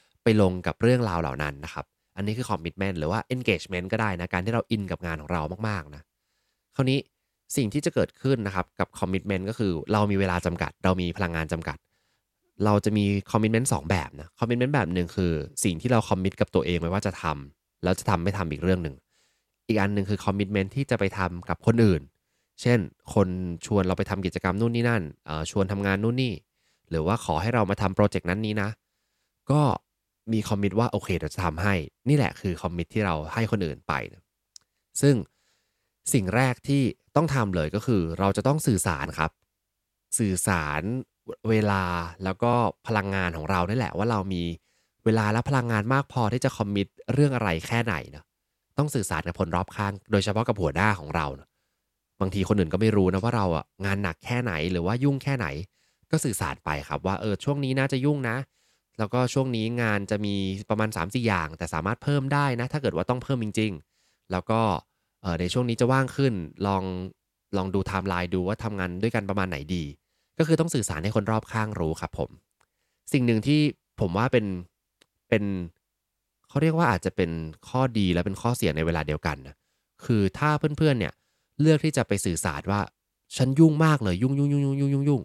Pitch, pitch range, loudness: 100 Hz, 90-120 Hz, -26 LUFS